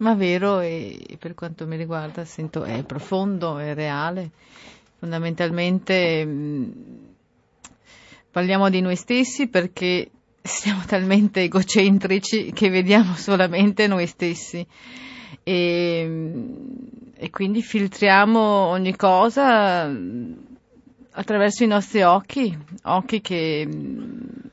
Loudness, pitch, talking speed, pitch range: -21 LUFS, 190 Hz, 95 wpm, 170-215 Hz